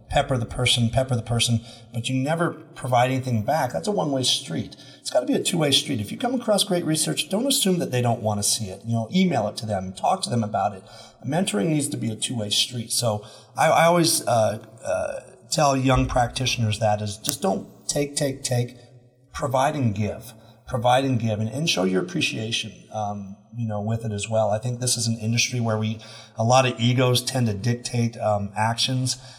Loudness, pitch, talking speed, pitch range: -23 LUFS, 120 Hz, 215 wpm, 110-135 Hz